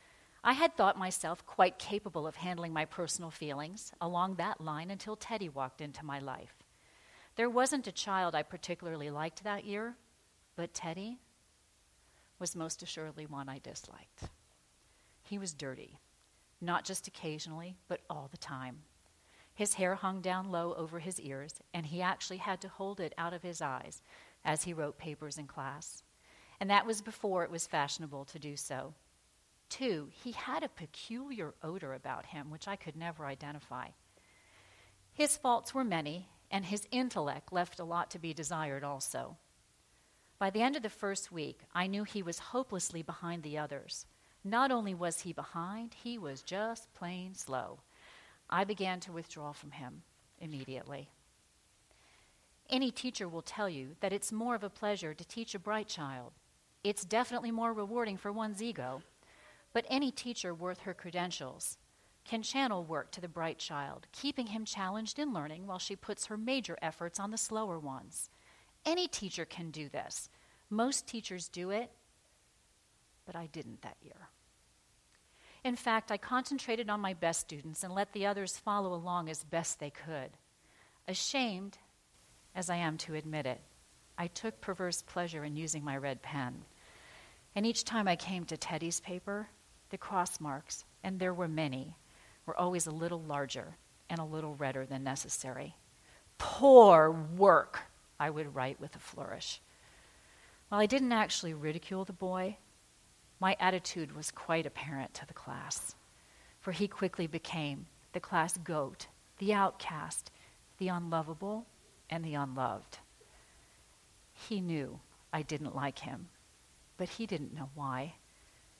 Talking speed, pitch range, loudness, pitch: 160 wpm, 150-205 Hz, -36 LUFS, 175 Hz